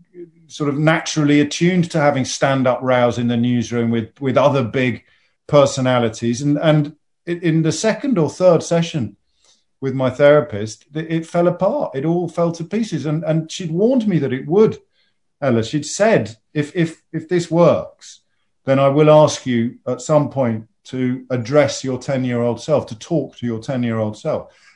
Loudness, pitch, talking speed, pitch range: -18 LUFS, 145 Hz, 170 wpm, 125-165 Hz